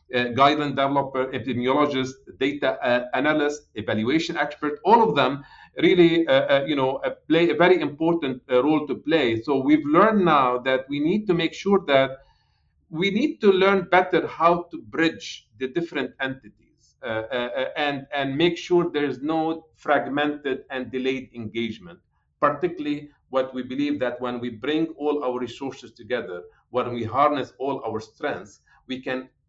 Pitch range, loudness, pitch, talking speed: 130-160 Hz, -23 LUFS, 140 Hz, 160 wpm